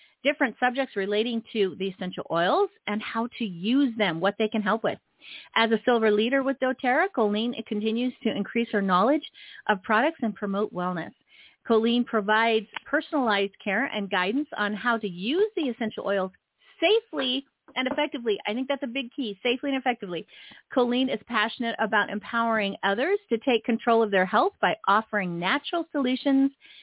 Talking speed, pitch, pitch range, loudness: 170 wpm, 230 Hz, 210-275 Hz, -26 LUFS